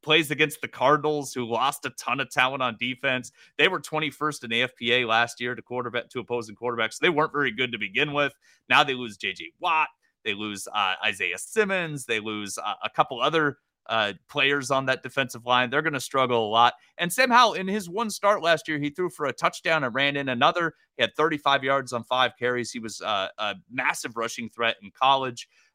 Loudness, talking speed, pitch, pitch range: -25 LUFS, 215 wpm, 130 Hz, 120-155 Hz